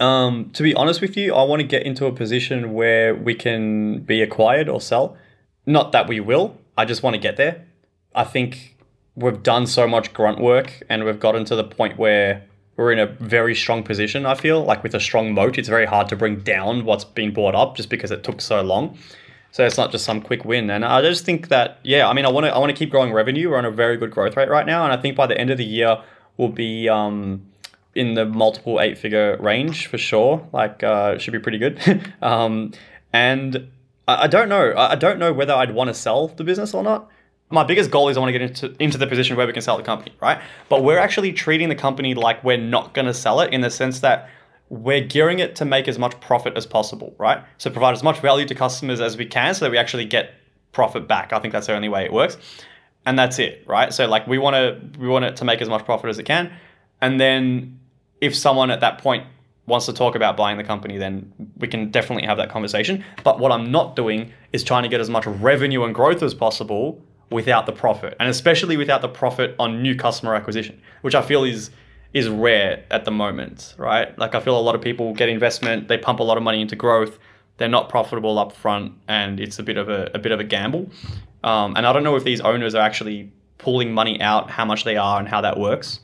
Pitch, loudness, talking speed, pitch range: 120 Hz, -19 LUFS, 245 wpm, 110-130 Hz